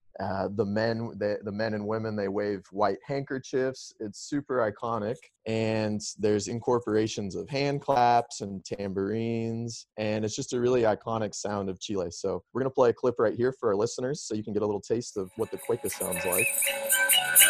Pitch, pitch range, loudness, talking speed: 110 Hz, 105-130 Hz, -29 LUFS, 195 wpm